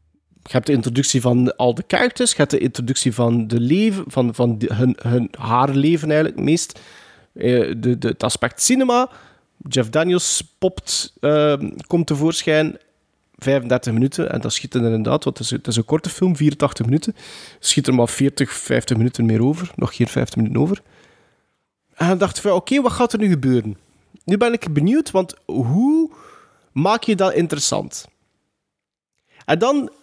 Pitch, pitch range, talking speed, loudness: 145 Hz, 125-185 Hz, 180 wpm, -19 LUFS